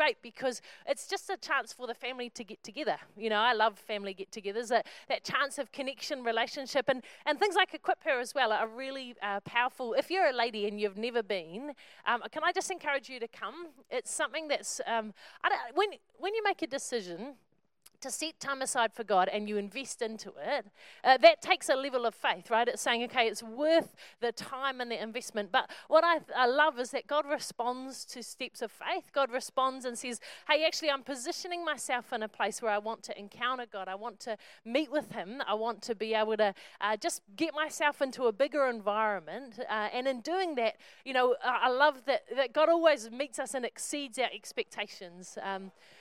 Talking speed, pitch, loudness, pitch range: 215 wpm, 250 Hz, -32 LUFS, 225-295 Hz